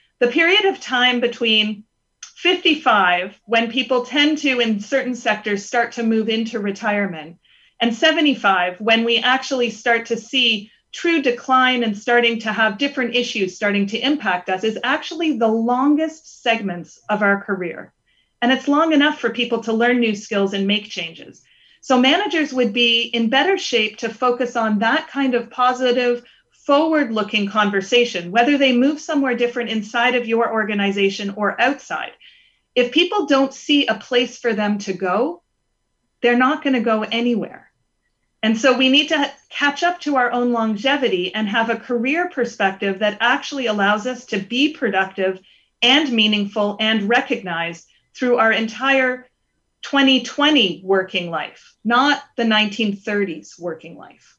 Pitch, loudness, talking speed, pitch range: 240 Hz, -18 LUFS, 155 wpm, 215-265 Hz